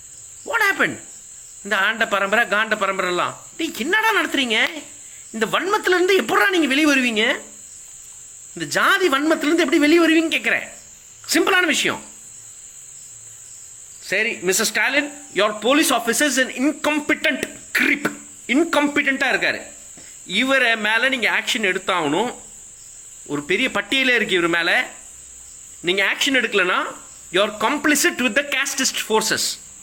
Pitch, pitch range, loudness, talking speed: 265 Hz, 205-310 Hz, -18 LUFS, 110 wpm